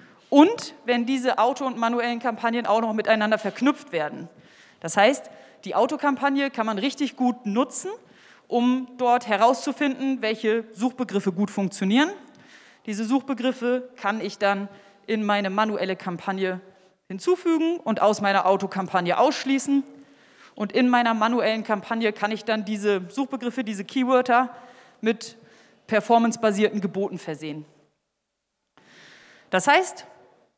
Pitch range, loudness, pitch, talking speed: 205-260 Hz, -23 LUFS, 230 Hz, 120 wpm